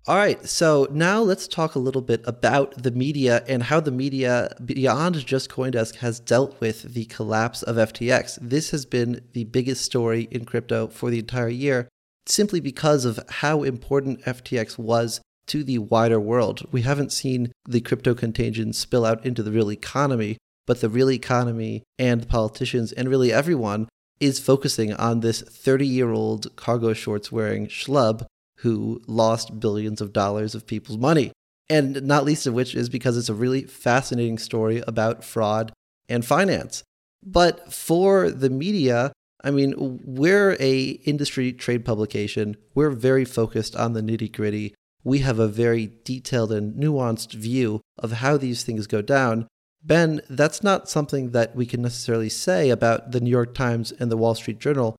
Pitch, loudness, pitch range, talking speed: 125 Hz, -23 LUFS, 115-135 Hz, 170 wpm